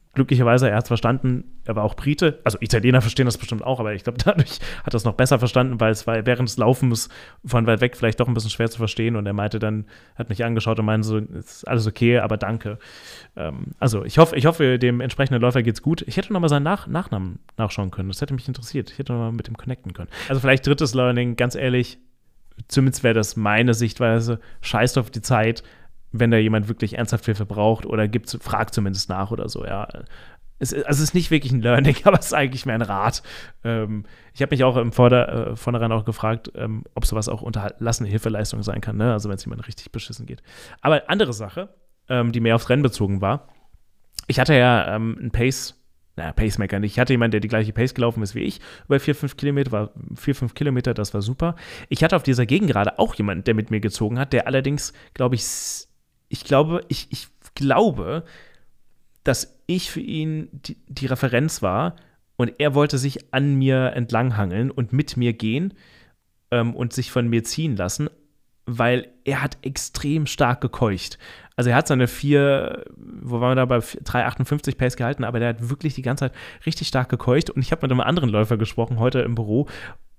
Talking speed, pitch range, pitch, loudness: 215 wpm, 110-135 Hz, 120 Hz, -21 LUFS